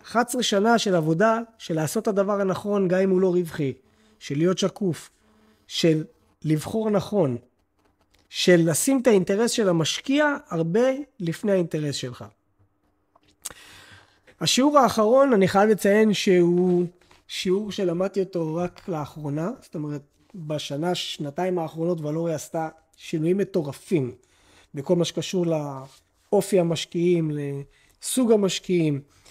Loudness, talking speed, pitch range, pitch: -23 LUFS, 115 wpm, 145-200 Hz, 175 Hz